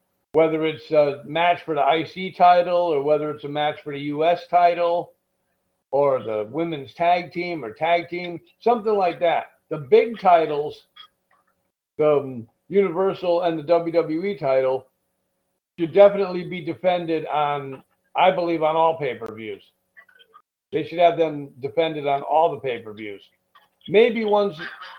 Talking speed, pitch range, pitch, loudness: 150 wpm, 150-180 Hz, 165 Hz, -21 LUFS